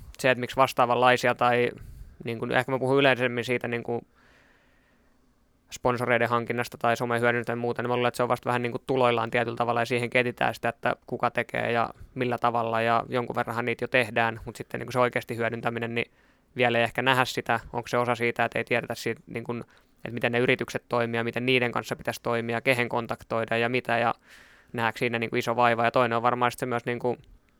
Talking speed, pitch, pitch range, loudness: 220 wpm, 120 Hz, 115-125 Hz, -26 LUFS